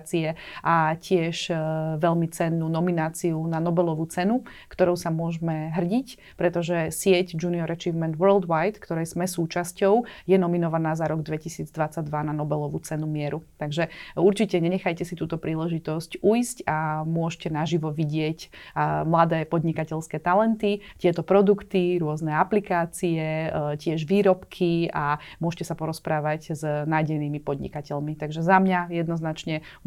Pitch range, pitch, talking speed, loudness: 155-180 Hz, 165 Hz, 120 wpm, -25 LUFS